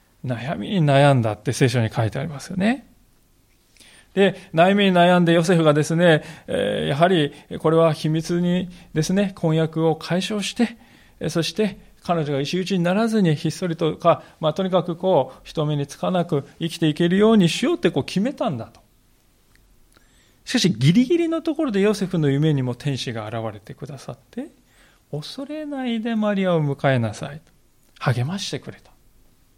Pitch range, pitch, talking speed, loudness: 145-195 Hz, 170 Hz, 325 characters per minute, -21 LUFS